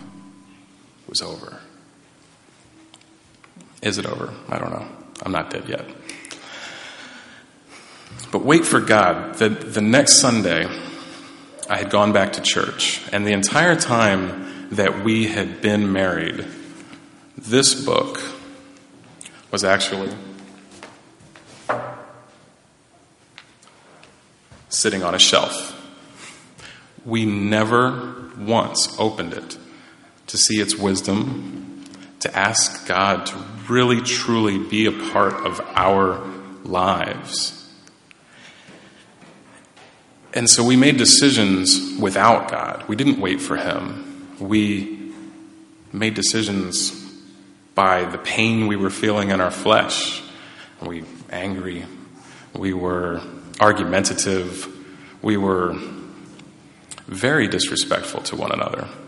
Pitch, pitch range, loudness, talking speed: 100 Hz, 95-115 Hz, -19 LUFS, 105 wpm